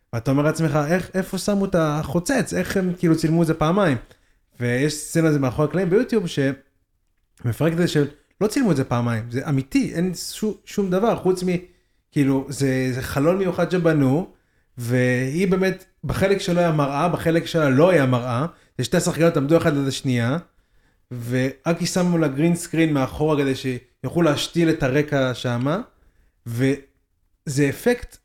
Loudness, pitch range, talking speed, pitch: -21 LUFS, 130-175 Hz, 160 wpm, 150 Hz